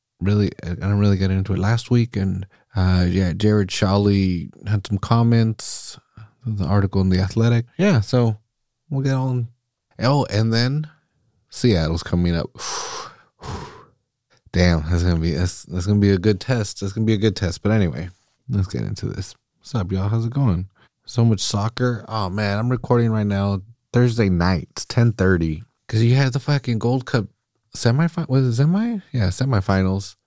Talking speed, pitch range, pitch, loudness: 175 wpm, 95-120 Hz, 110 Hz, -20 LUFS